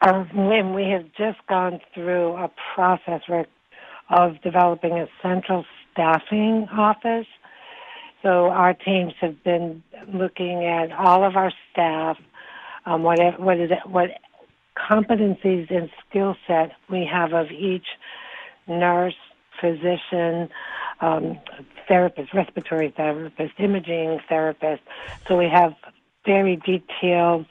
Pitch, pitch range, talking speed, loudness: 180 Hz, 170-190 Hz, 120 wpm, -22 LUFS